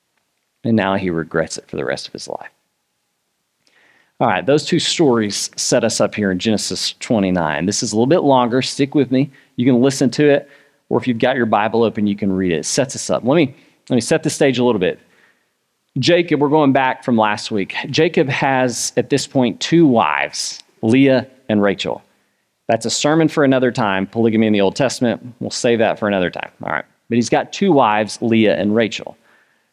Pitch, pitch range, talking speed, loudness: 125 Hz, 105-140 Hz, 215 wpm, -17 LUFS